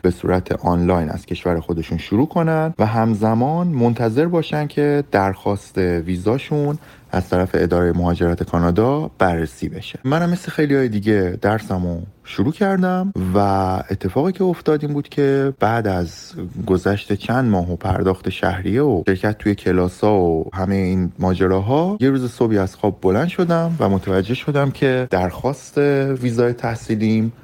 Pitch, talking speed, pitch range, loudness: 105 Hz, 145 wpm, 95-140 Hz, -19 LUFS